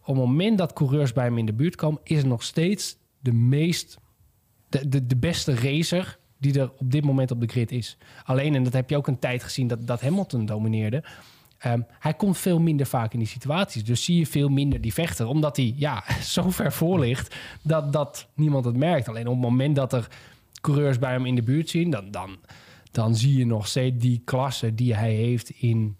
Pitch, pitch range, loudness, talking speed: 130 Hz, 120-150 Hz, -24 LUFS, 225 wpm